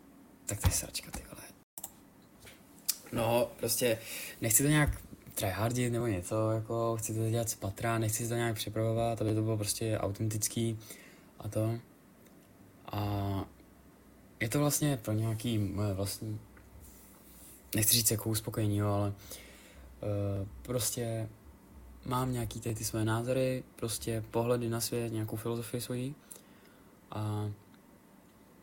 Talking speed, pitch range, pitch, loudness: 130 wpm, 105-115 Hz, 110 Hz, -33 LUFS